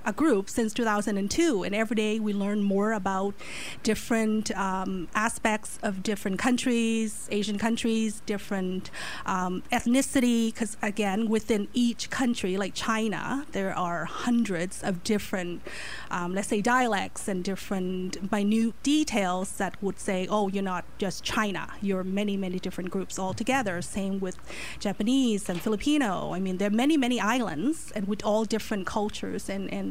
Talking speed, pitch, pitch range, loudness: 155 wpm, 210 Hz, 195-230 Hz, -28 LUFS